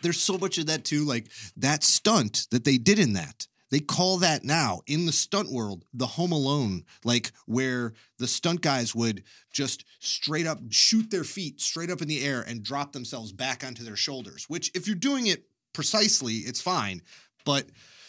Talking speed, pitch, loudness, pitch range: 190 wpm, 140 Hz, -26 LUFS, 120-170 Hz